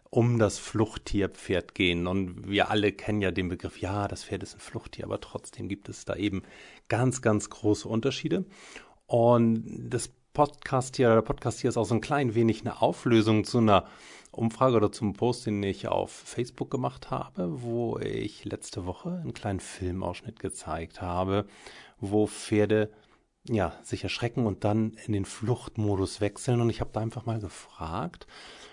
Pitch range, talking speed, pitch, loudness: 100-120 Hz, 170 wpm, 110 Hz, -29 LUFS